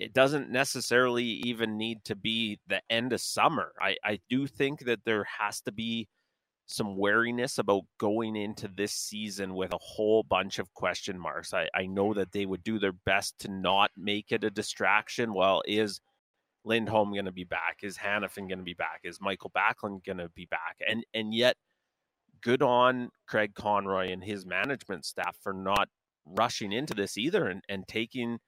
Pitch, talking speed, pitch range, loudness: 105 Hz, 180 wpm, 100-115 Hz, -30 LUFS